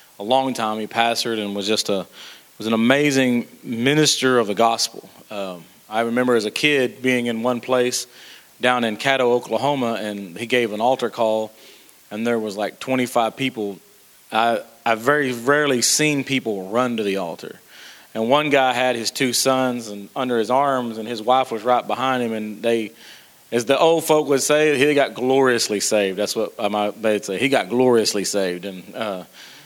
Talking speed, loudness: 190 wpm, -20 LUFS